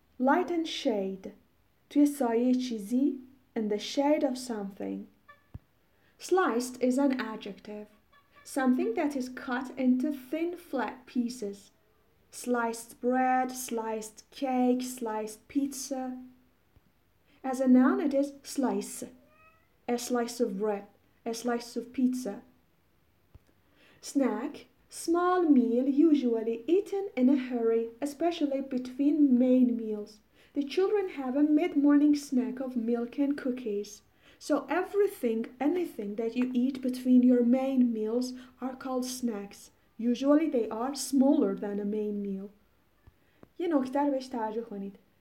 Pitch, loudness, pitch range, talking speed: 255 Hz, -29 LUFS, 230-280 Hz, 120 wpm